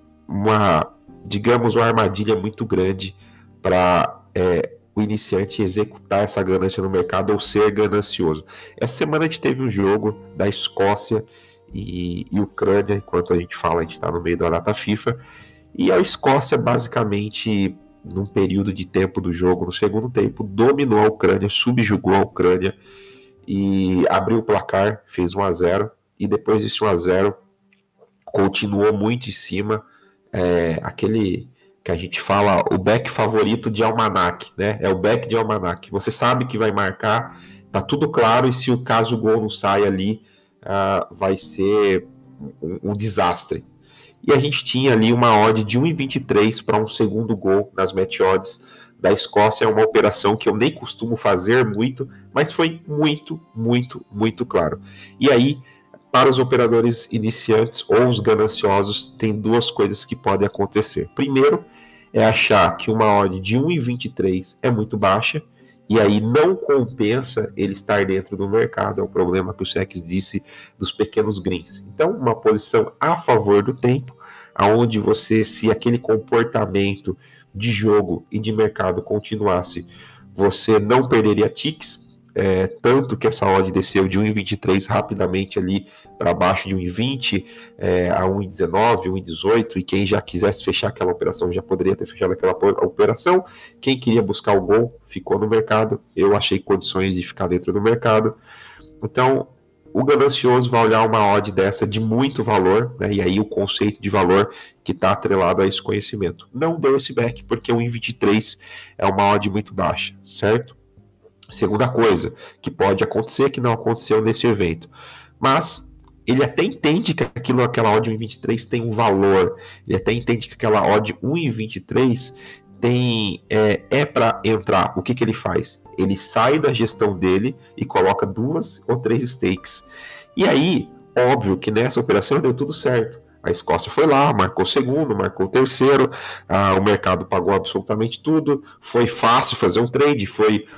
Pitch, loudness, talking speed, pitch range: 105 Hz, -19 LUFS, 165 wpm, 100-120 Hz